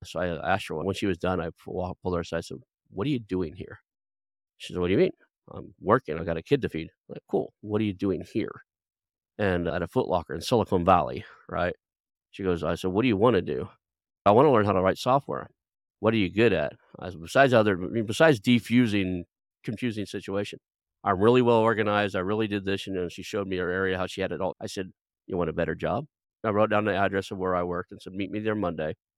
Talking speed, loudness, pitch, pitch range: 255 wpm, -26 LUFS, 95 Hz, 90-105 Hz